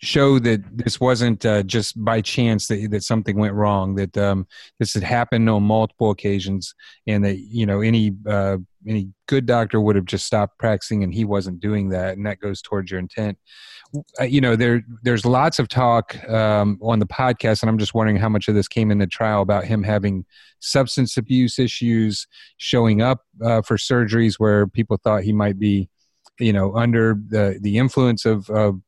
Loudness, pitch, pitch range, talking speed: -20 LUFS, 110 Hz, 100-115 Hz, 195 wpm